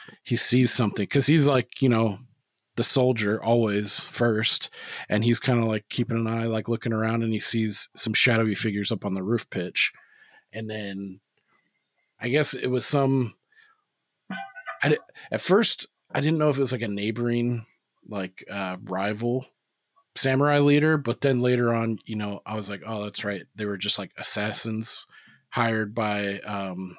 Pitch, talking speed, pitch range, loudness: 115 Hz, 175 wpm, 105-125 Hz, -24 LUFS